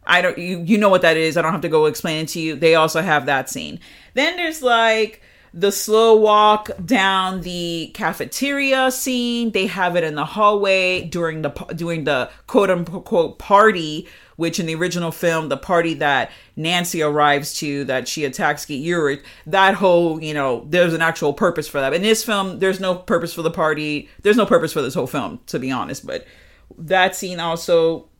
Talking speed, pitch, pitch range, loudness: 200 wpm, 175 Hz, 160-200 Hz, -18 LUFS